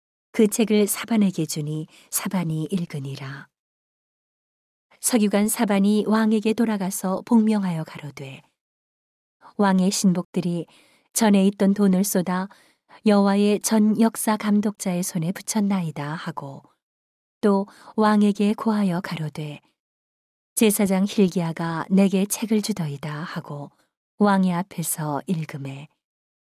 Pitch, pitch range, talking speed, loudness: 190 Hz, 160-210 Hz, 240 characters per minute, -22 LUFS